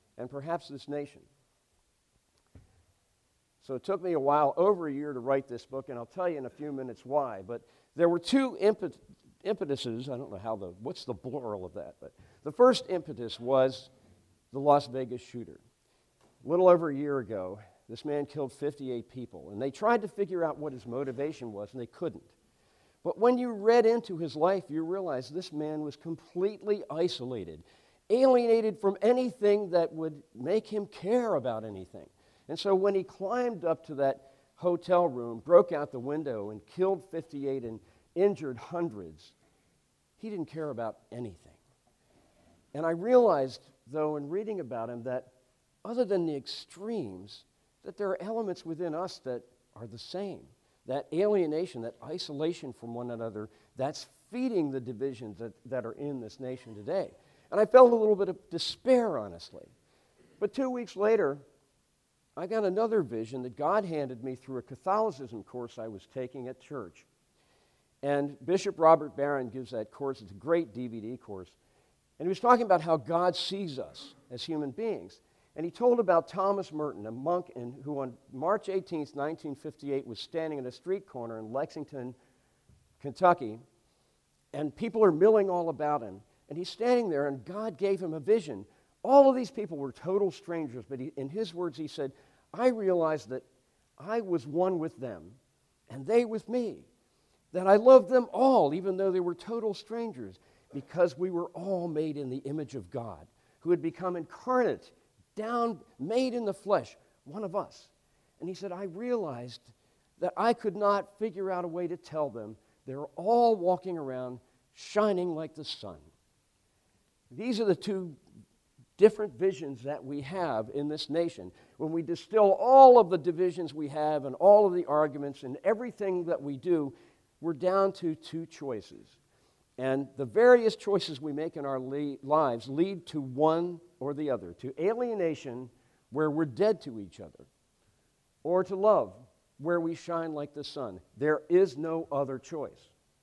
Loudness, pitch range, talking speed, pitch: -30 LUFS, 130-190 Hz, 175 wpm, 155 Hz